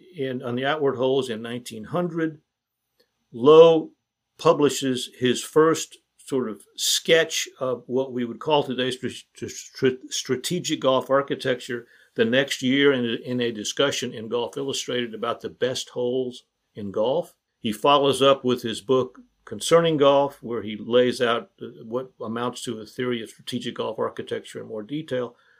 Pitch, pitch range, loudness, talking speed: 130 Hz, 125-150 Hz, -23 LUFS, 150 wpm